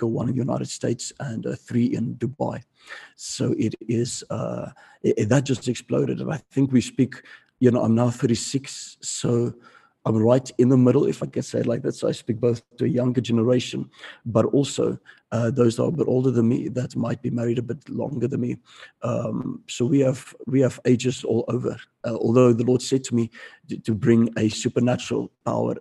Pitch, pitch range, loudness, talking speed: 120 Hz, 115-130 Hz, -23 LUFS, 210 wpm